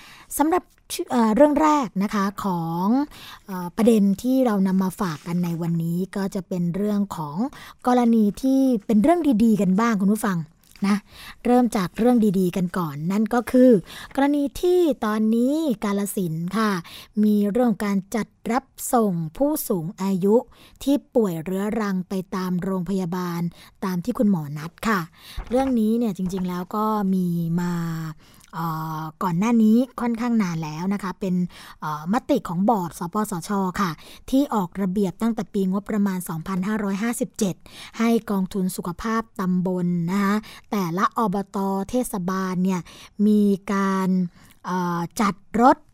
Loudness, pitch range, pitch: -23 LUFS, 185-230 Hz, 200 Hz